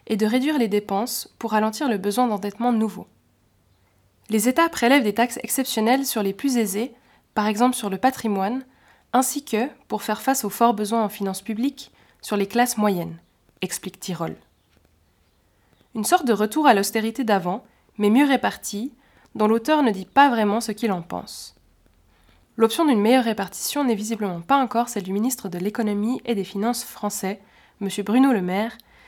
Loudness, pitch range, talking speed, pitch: -22 LUFS, 195-245 Hz, 175 wpm, 220 Hz